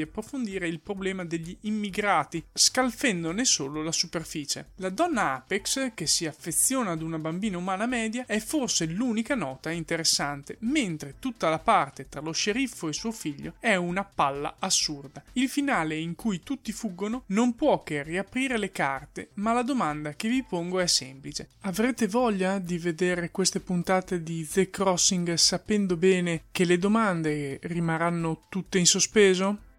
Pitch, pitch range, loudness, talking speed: 185 Hz, 165-220 Hz, -27 LUFS, 155 wpm